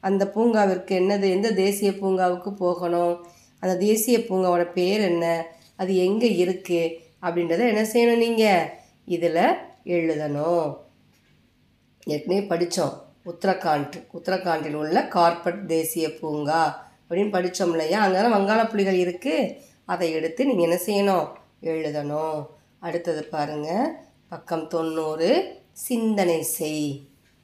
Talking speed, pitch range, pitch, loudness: 105 wpm, 165-200 Hz, 175 Hz, -23 LUFS